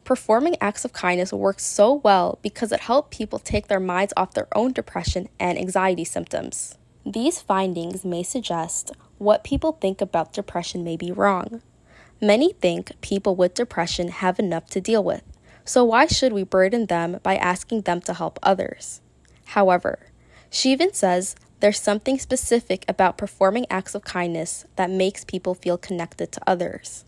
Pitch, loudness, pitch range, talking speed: 195 Hz, -22 LUFS, 180-230 Hz, 165 wpm